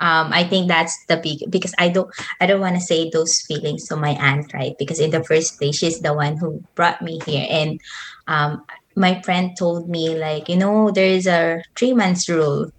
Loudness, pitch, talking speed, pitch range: -19 LUFS, 165 Hz, 210 wpm, 155-180 Hz